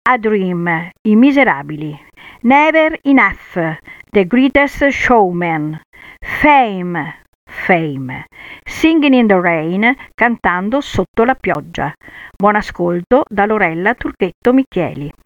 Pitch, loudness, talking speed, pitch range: 200 Hz, -13 LUFS, 100 wpm, 170-260 Hz